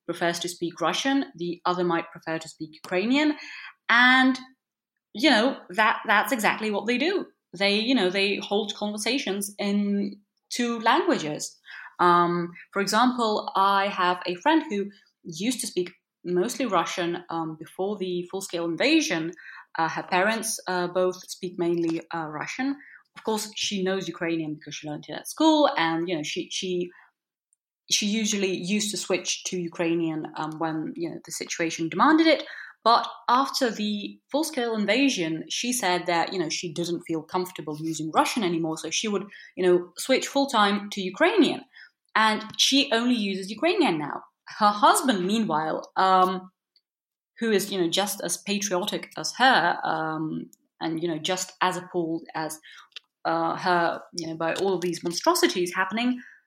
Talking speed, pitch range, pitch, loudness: 160 wpm, 170-230 Hz, 190 Hz, -25 LUFS